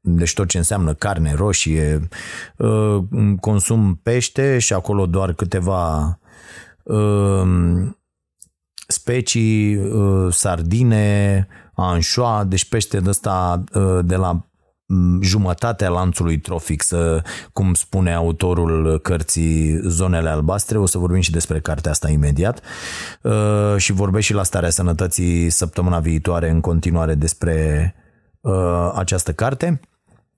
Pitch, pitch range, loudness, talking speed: 90 Hz, 85-100 Hz, -18 LUFS, 100 wpm